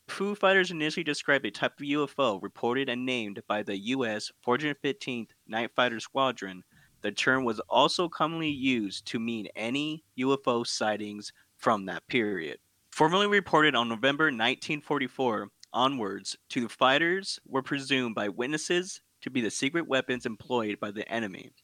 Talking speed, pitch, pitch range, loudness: 155 wpm, 130 Hz, 115-155 Hz, -29 LUFS